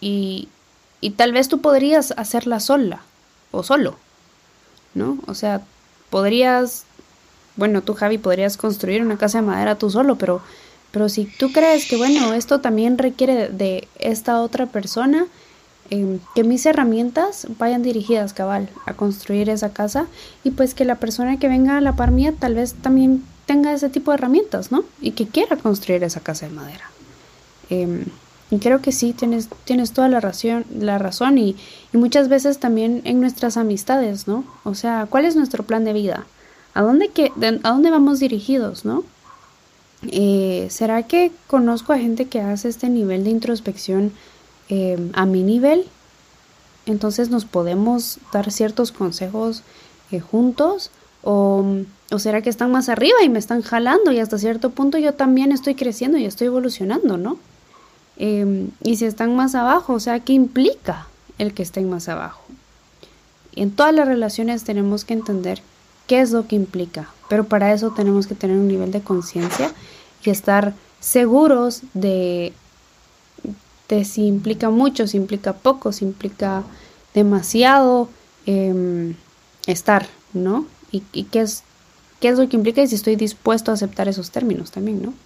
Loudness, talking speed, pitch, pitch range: -19 LUFS, 165 wpm, 225 Hz, 200-260 Hz